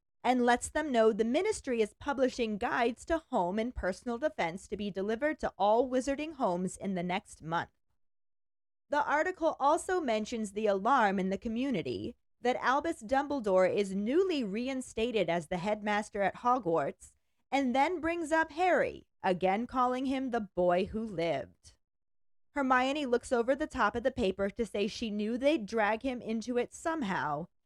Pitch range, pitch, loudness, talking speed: 205-275 Hz, 235 Hz, -32 LUFS, 165 wpm